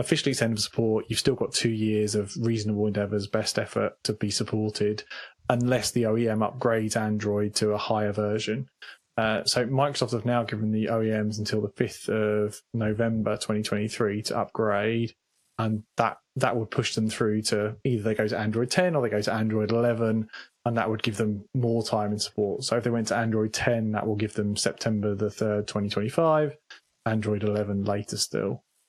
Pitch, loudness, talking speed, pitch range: 110 Hz, -27 LUFS, 185 wpm, 105-115 Hz